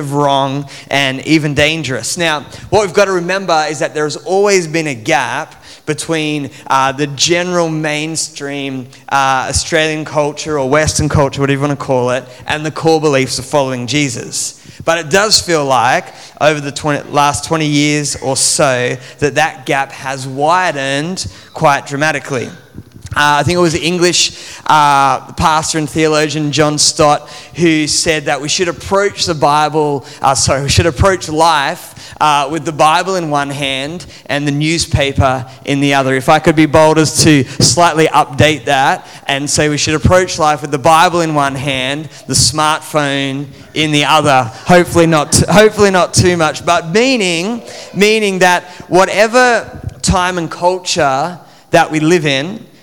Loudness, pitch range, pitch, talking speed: -12 LUFS, 140-165 Hz, 150 Hz, 170 wpm